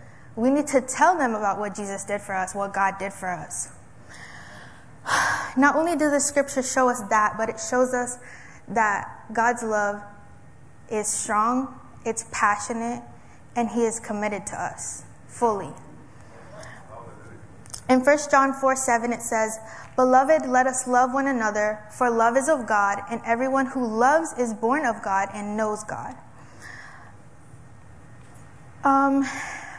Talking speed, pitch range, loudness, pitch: 145 wpm, 205-260 Hz, -23 LUFS, 230 Hz